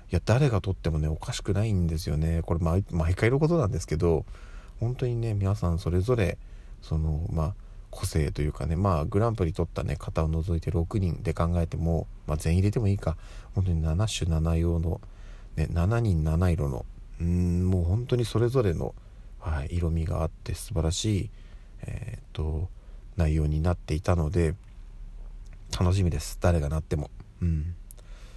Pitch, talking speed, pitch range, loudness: 90 Hz, 320 characters per minute, 80-100 Hz, -28 LUFS